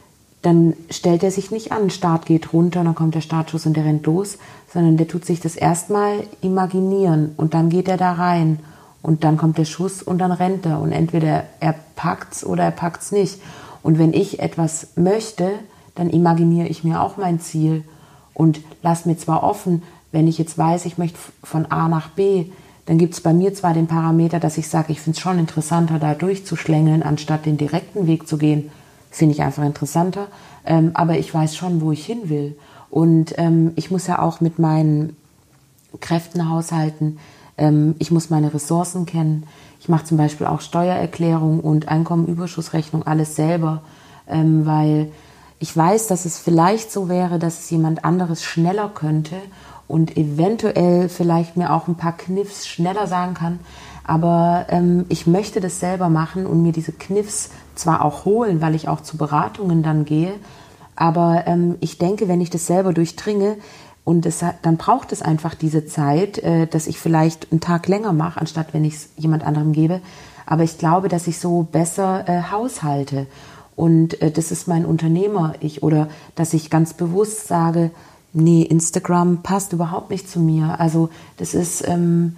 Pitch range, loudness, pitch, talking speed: 155-175 Hz, -19 LUFS, 165 Hz, 180 wpm